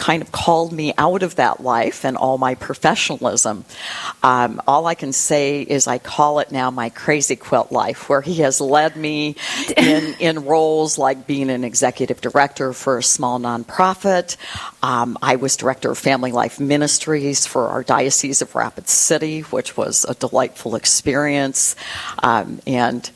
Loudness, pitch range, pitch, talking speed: -18 LUFS, 130-155 Hz, 140 Hz, 165 wpm